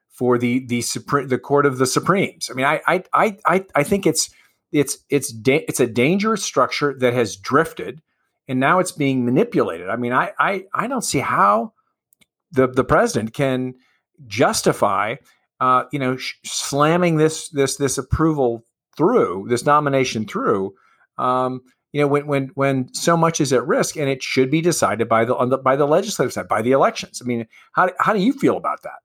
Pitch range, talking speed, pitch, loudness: 125-155 Hz, 195 wpm, 135 Hz, -19 LUFS